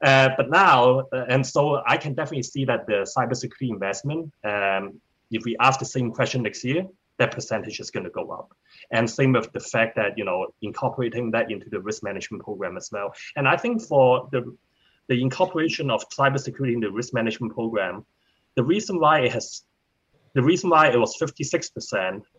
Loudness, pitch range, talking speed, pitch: -23 LUFS, 120-150 Hz, 200 wpm, 130 Hz